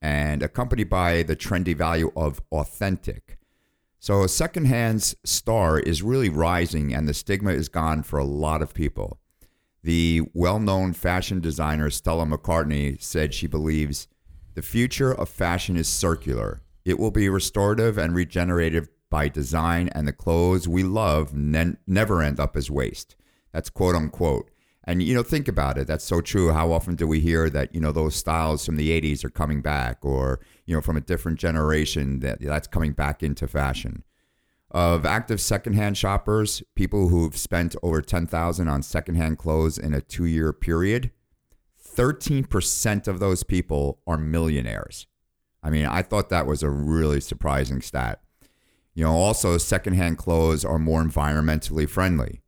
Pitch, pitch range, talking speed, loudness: 80 Hz, 75-90 Hz, 160 wpm, -24 LUFS